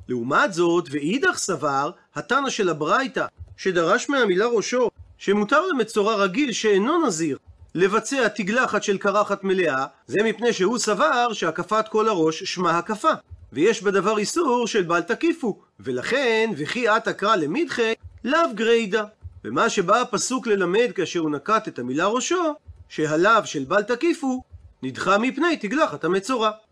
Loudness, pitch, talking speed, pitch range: -22 LUFS, 210 Hz, 135 wpm, 175-240 Hz